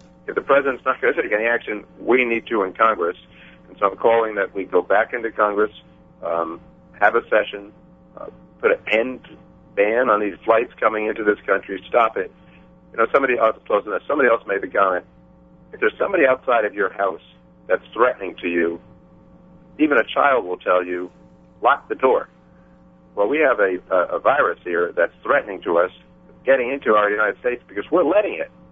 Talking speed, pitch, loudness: 195 wpm, 85 Hz, -20 LUFS